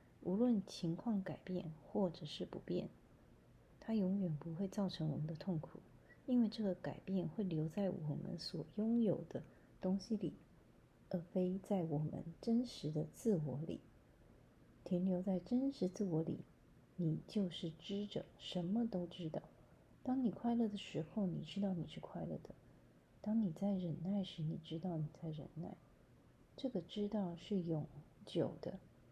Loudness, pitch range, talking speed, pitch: -42 LUFS, 165-205 Hz, 220 characters per minute, 185 Hz